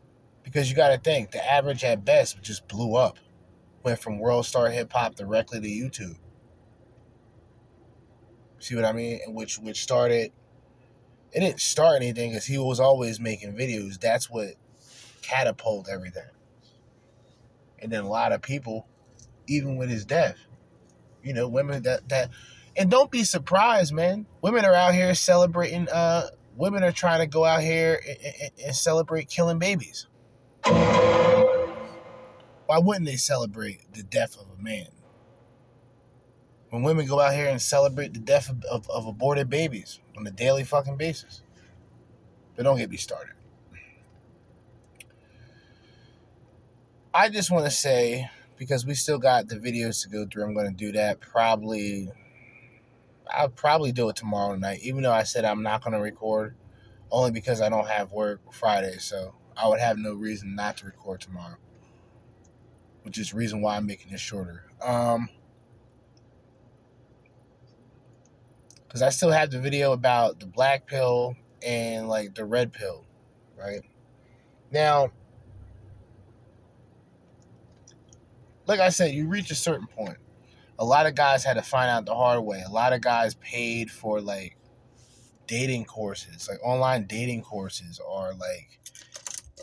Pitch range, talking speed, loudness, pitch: 110-135 Hz, 150 wpm, -25 LUFS, 120 Hz